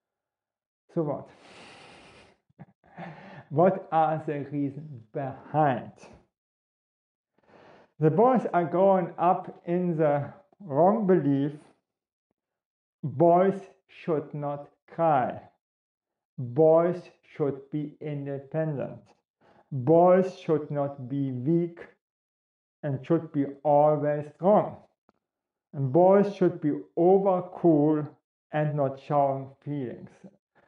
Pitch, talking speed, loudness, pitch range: 155 Hz, 85 wpm, -26 LUFS, 145-175 Hz